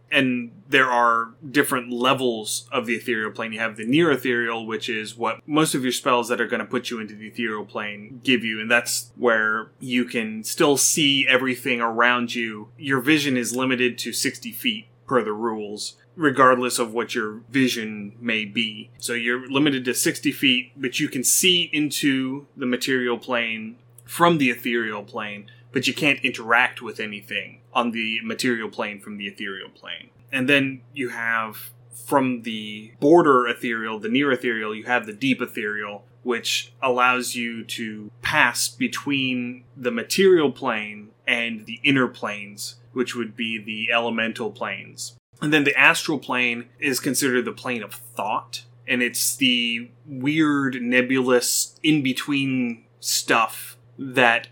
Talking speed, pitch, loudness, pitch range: 160 wpm, 120 Hz, -22 LUFS, 115-130 Hz